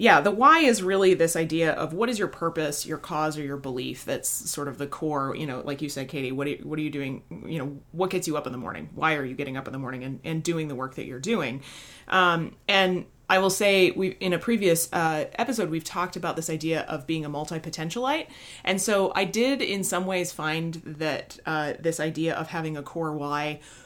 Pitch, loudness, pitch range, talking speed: 160 Hz, -26 LUFS, 150-185 Hz, 245 wpm